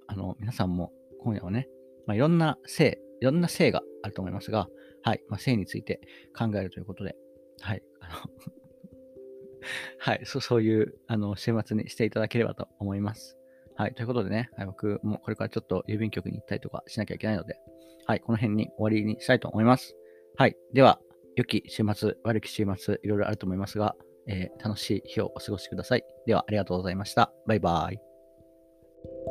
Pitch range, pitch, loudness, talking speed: 95-125 Hz, 110 Hz, -29 LUFS, 400 characters per minute